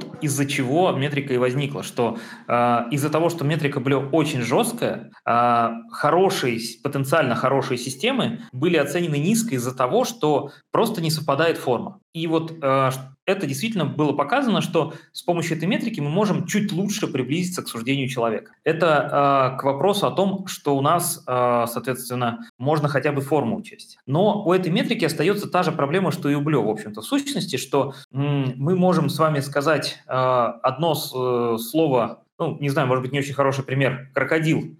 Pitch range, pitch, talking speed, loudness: 130-170 Hz, 145 Hz, 165 wpm, -22 LUFS